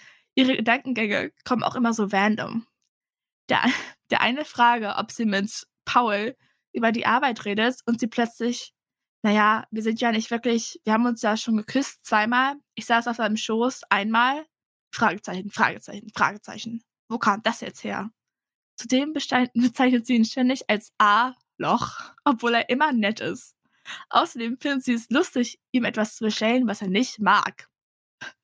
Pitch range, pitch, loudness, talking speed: 215-250 Hz, 230 Hz, -23 LUFS, 155 wpm